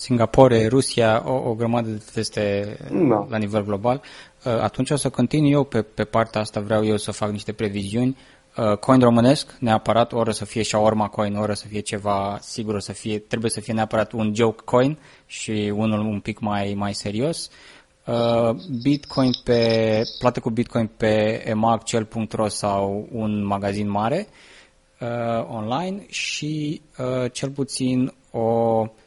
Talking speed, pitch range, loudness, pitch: 160 wpm, 105-125 Hz, -22 LUFS, 110 Hz